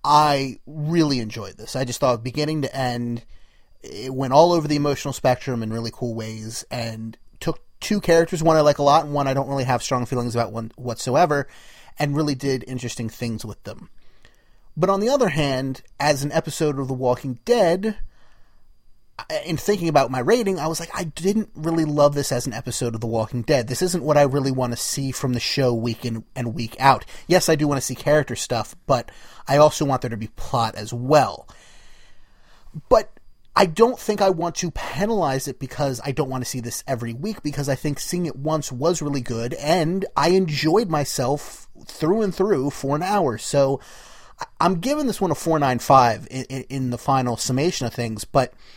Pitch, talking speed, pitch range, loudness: 135 Hz, 205 wpm, 120-160 Hz, -22 LUFS